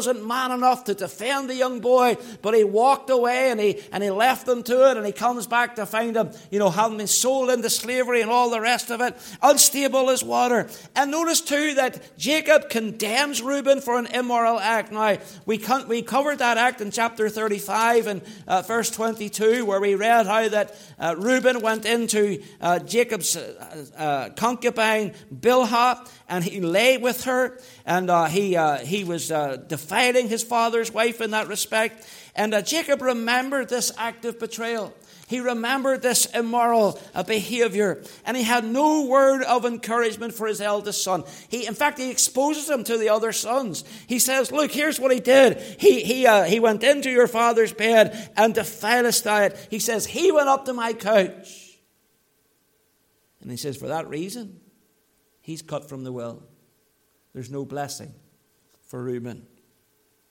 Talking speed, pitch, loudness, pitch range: 180 wpm, 230 Hz, -22 LUFS, 205-250 Hz